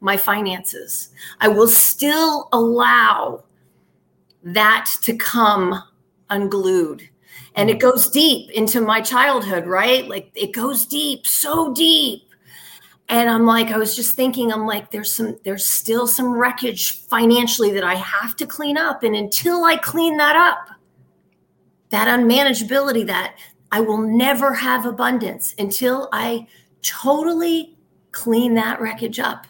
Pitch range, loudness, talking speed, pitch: 215-270 Hz, -17 LUFS, 135 wpm, 230 Hz